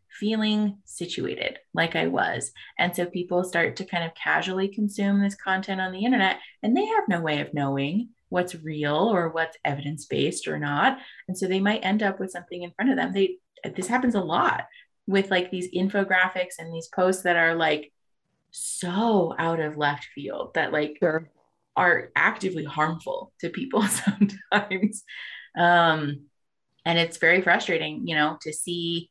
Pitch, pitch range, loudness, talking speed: 180 Hz, 165-200 Hz, -25 LUFS, 170 wpm